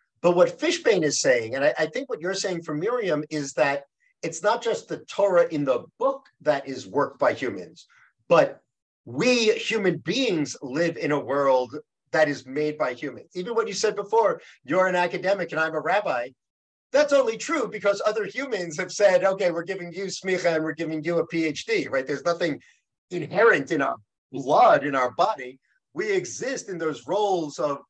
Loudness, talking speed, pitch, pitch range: -24 LUFS, 190 wpm, 175 Hz, 150-220 Hz